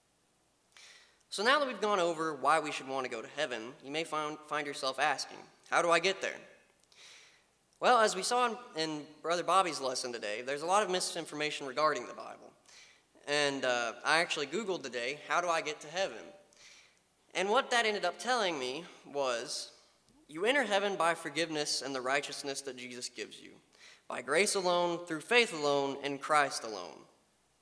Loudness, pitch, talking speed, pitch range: -32 LUFS, 160 Hz, 185 wpm, 145-195 Hz